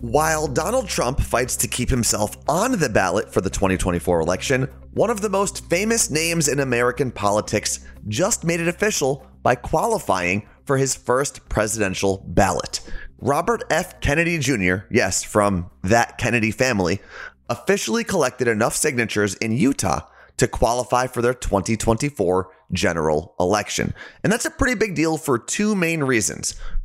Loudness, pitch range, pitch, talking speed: -21 LUFS, 100-155 Hz, 120 Hz, 145 wpm